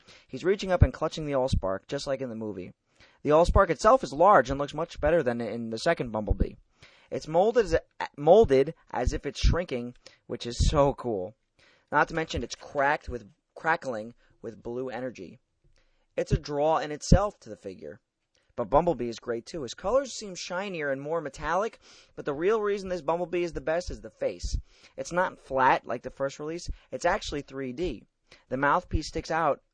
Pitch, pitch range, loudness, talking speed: 140 Hz, 120-170 Hz, -28 LUFS, 185 wpm